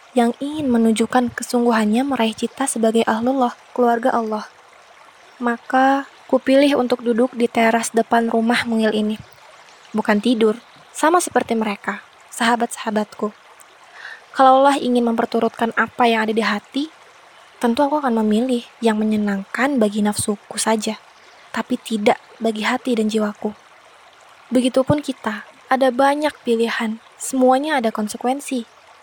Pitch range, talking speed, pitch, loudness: 225-260 Hz, 120 wpm, 235 Hz, -19 LUFS